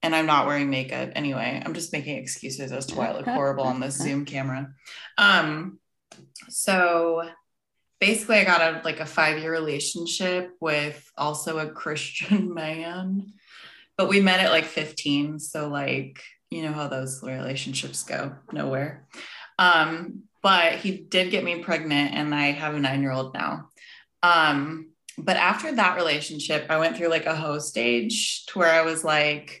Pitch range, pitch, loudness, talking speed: 145-180 Hz, 160 Hz, -24 LUFS, 170 wpm